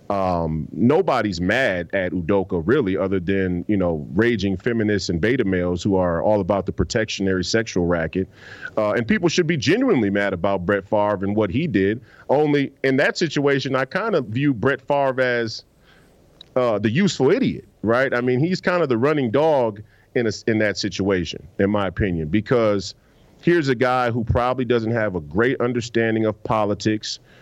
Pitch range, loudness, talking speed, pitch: 95-125 Hz, -21 LUFS, 180 wpm, 110 Hz